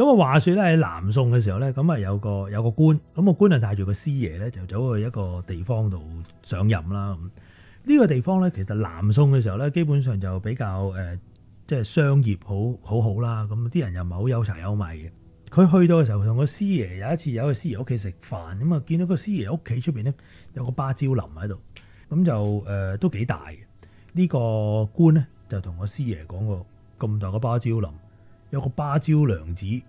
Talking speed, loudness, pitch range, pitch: 305 characters per minute, -23 LUFS, 100-145 Hz, 110 Hz